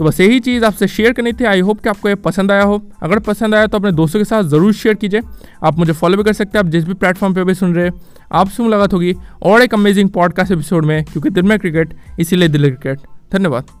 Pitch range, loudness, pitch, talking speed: 170-215 Hz, -13 LUFS, 195 Hz, 260 wpm